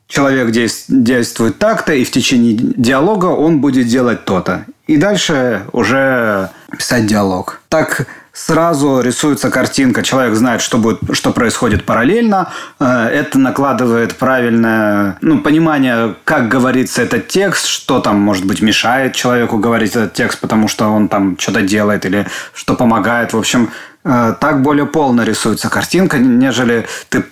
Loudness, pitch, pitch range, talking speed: -12 LUFS, 125 Hz, 110-145 Hz, 140 wpm